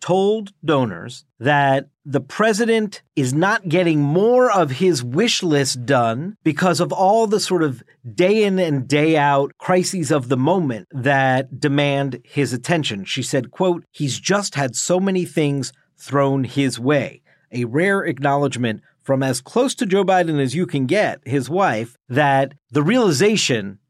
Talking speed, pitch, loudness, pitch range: 160 wpm, 150 Hz, -19 LUFS, 135-180 Hz